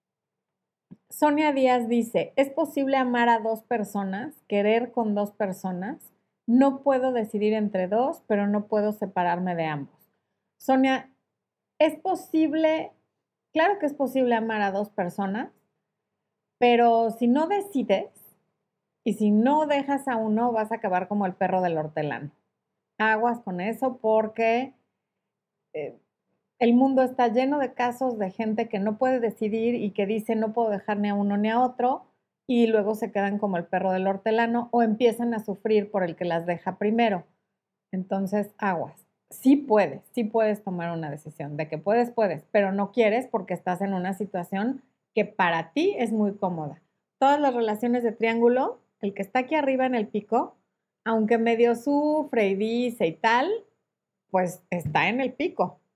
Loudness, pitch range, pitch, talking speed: -25 LUFS, 200-250 Hz, 220 Hz, 165 wpm